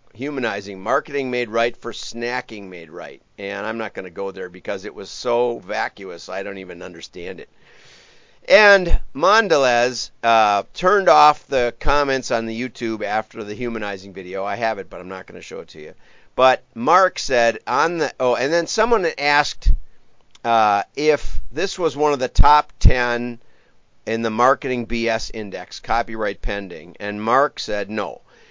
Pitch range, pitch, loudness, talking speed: 105-140 Hz, 120 Hz, -19 LUFS, 170 wpm